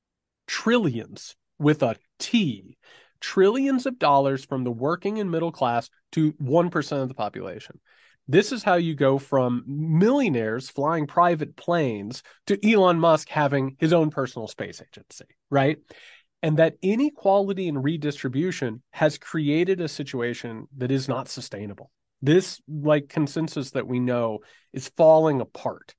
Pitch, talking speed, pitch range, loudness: 150 Hz, 140 wpm, 130-170 Hz, -23 LUFS